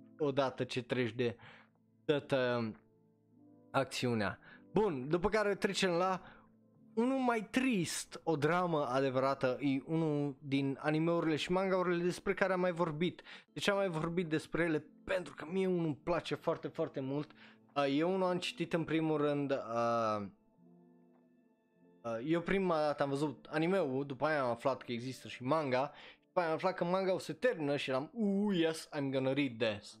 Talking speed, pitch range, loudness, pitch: 165 wpm, 130-180 Hz, -35 LUFS, 150 Hz